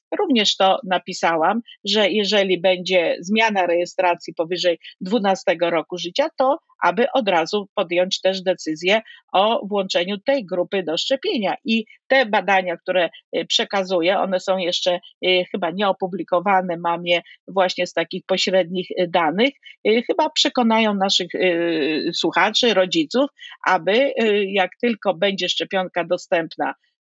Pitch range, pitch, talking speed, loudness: 180-225 Hz, 190 Hz, 120 wpm, -20 LUFS